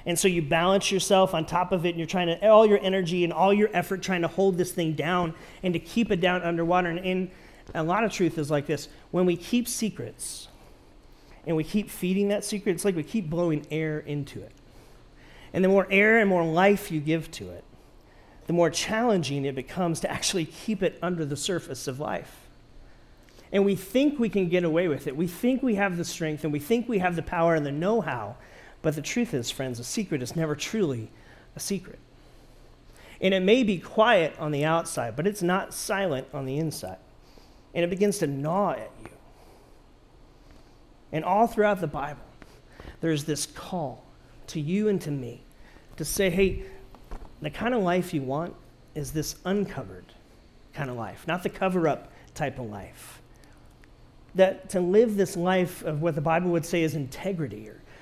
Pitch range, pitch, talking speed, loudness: 150-195 Hz, 170 Hz, 200 wpm, -26 LUFS